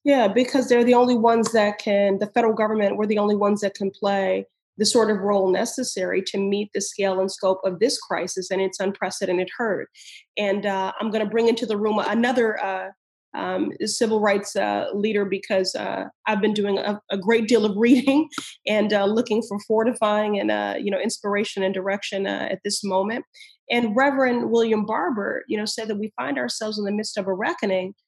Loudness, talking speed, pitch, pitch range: -22 LUFS, 205 wpm, 210 Hz, 195-225 Hz